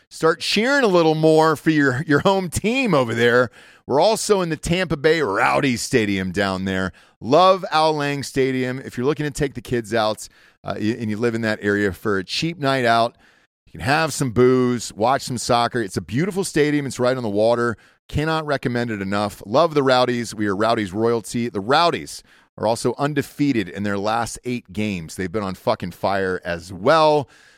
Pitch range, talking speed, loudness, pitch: 110-150 Hz, 200 wpm, -20 LUFS, 125 Hz